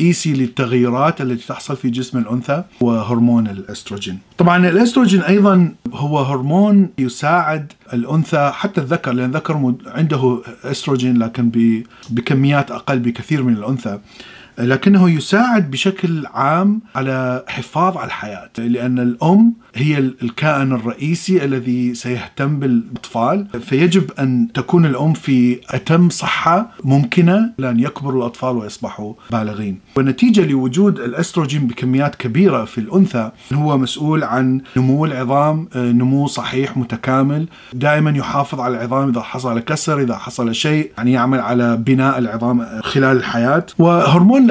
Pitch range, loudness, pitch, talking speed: 120-160 Hz, -16 LUFS, 135 Hz, 120 wpm